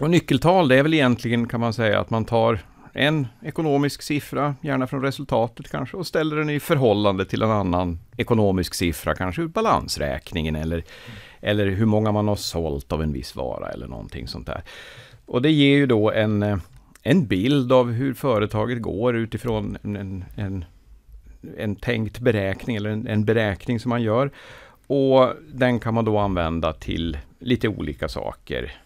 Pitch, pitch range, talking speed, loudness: 110 Hz, 95-130 Hz, 170 wpm, -22 LUFS